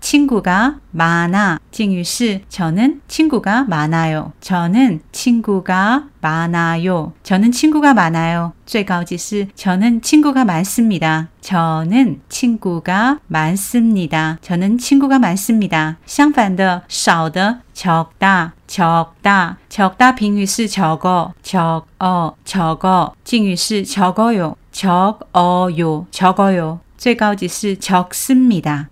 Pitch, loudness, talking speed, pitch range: 190 Hz, -15 LUFS, 195 characters per minute, 170-225 Hz